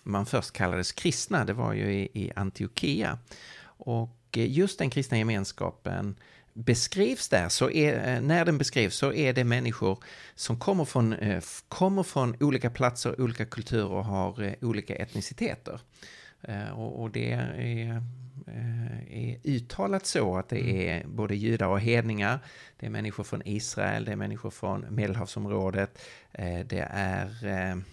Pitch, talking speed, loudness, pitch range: 115 Hz, 135 wpm, -29 LUFS, 100-125 Hz